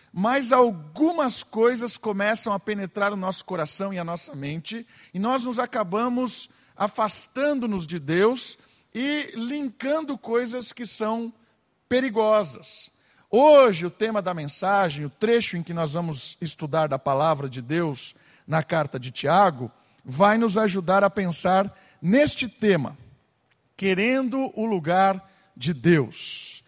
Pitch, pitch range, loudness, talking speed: 200 Hz, 165-235 Hz, -24 LUFS, 130 wpm